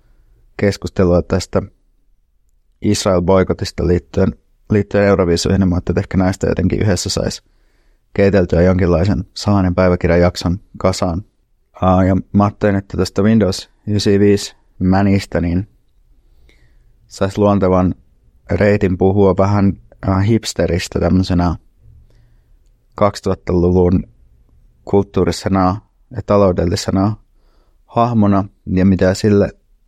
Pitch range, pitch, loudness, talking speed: 90-100 Hz, 95 Hz, -15 LUFS, 85 wpm